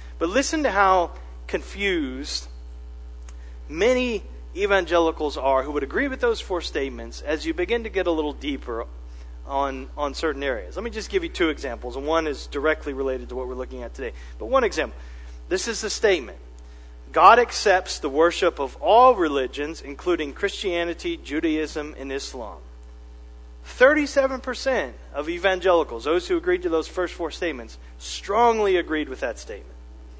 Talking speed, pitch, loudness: 160 wpm, 150 Hz, -23 LUFS